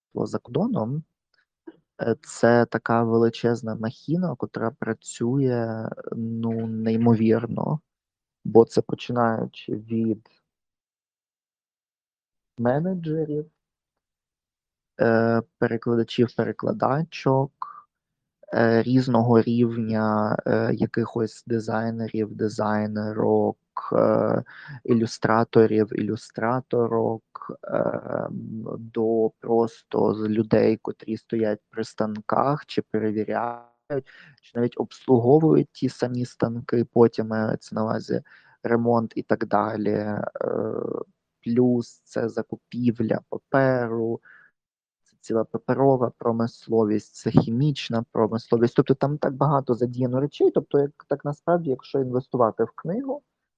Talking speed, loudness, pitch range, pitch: 80 wpm, -24 LUFS, 110-130 Hz, 115 Hz